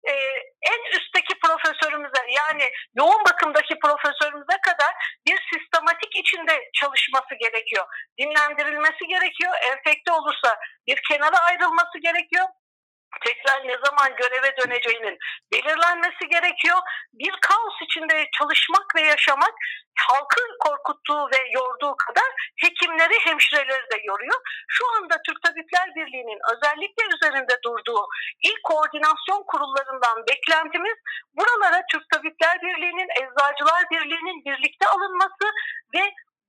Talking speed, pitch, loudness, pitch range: 105 wpm, 325 Hz, -21 LUFS, 285-370 Hz